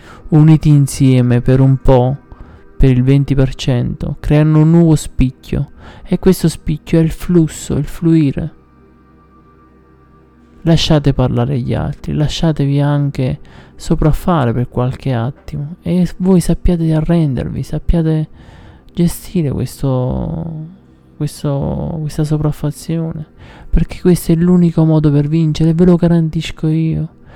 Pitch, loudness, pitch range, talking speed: 150 Hz, -14 LUFS, 130-165 Hz, 115 wpm